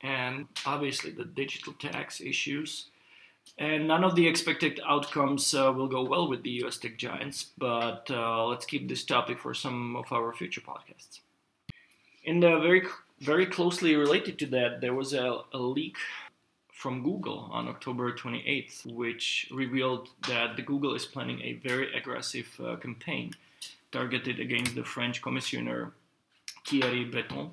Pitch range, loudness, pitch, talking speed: 120-150 Hz, -30 LUFS, 135 Hz, 150 wpm